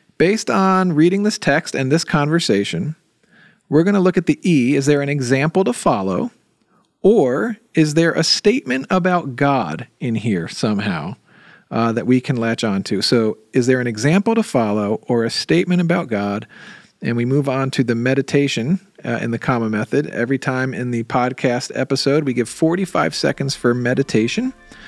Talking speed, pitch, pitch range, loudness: 180 wpm, 140 Hz, 120-175 Hz, -18 LUFS